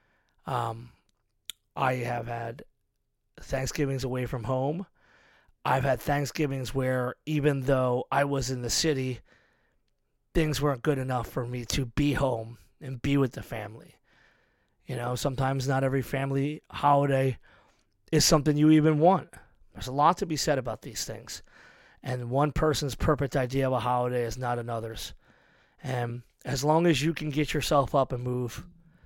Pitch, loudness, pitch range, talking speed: 135 Hz, -28 LUFS, 125-145 Hz, 155 wpm